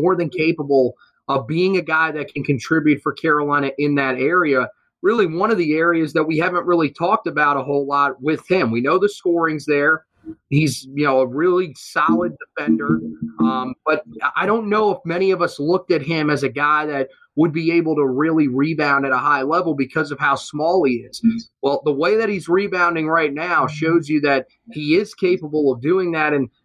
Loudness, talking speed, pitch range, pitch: -19 LUFS, 210 wpm, 140-170 Hz, 155 Hz